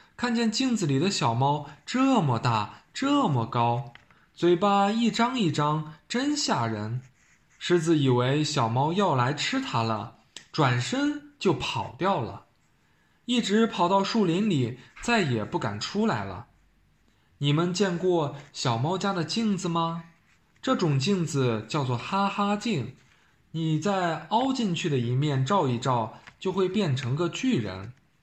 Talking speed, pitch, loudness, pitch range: 195 characters per minute, 165 Hz, -26 LUFS, 135-205 Hz